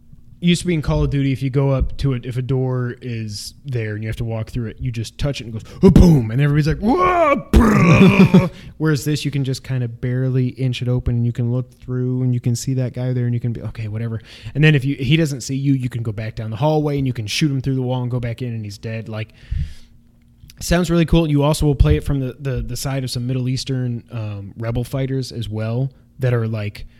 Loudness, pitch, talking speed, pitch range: -19 LUFS, 125 Hz, 270 wpm, 115-140 Hz